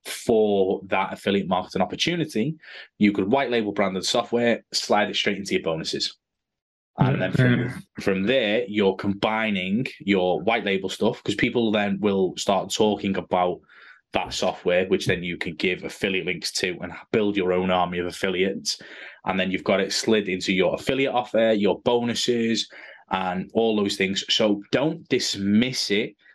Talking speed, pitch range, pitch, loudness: 165 wpm, 95-115 Hz, 105 Hz, -23 LUFS